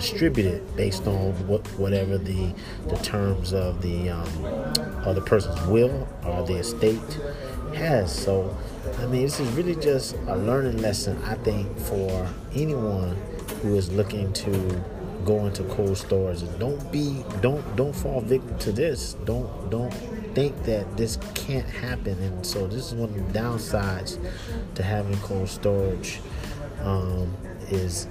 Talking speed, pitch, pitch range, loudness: 145 wpm, 100 Hz, 95-115 Hz, -27 LUFS